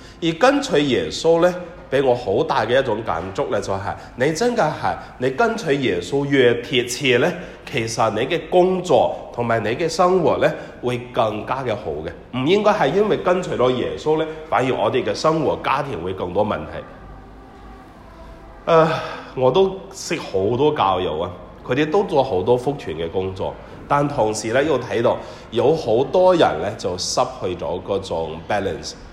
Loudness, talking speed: -20 LUFS, 250 characters per minute